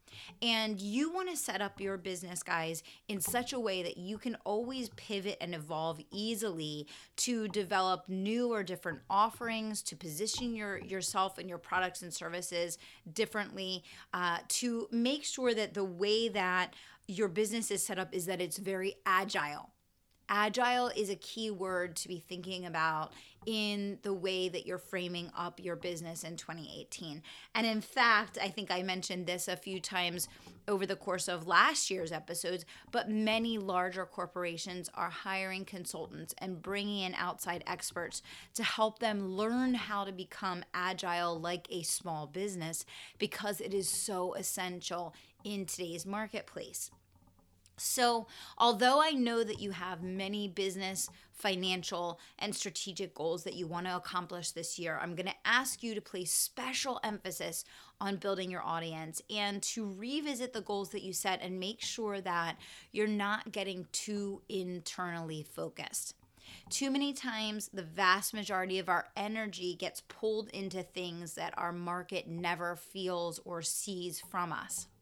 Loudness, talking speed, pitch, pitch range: -35 LUFS, 160 wpm, 190 Hz, 175-210 Hz